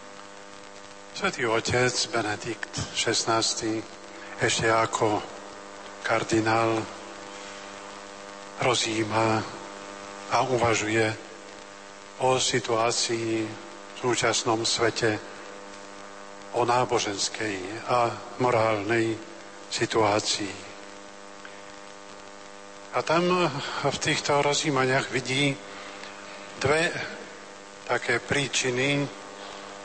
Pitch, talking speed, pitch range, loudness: 100 Hz, 60 wpm, 100-115 Hz, -26 LUFS